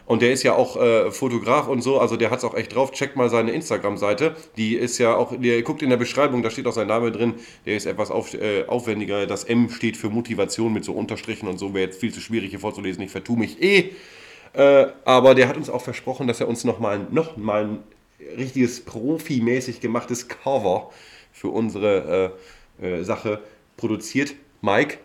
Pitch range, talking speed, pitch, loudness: 110-135 Hz, 210 wpm, 120 Hz, -22 LUFS